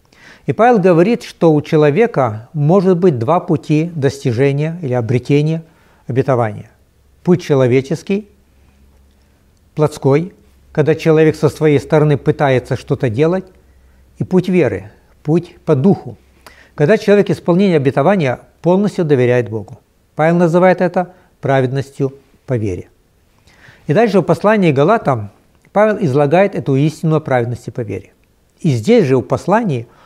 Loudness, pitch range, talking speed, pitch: -14 LUFS, 120-170 Hz, 125 wpm, 145 Hz